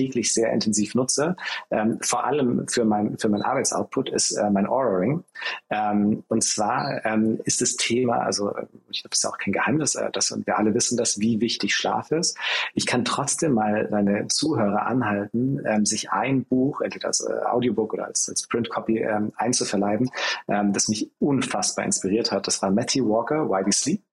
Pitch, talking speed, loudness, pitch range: 110 Hz, 185 wpm, -23 LUFS, 105-120 Hz